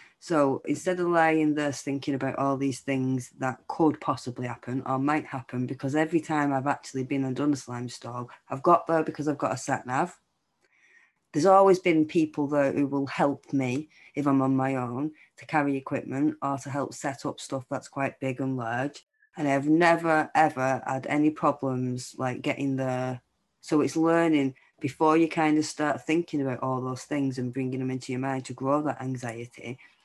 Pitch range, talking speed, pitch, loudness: 130-150 Hz, 190 wpm, 140 Hz, -27 LUFS